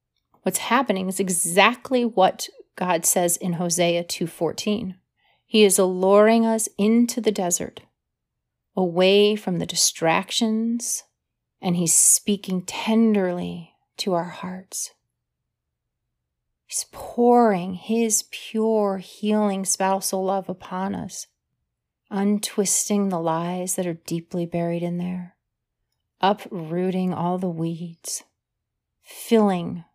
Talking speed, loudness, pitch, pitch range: 100 wpm, -22 LUFS, 190 Hz, 175-210 Hz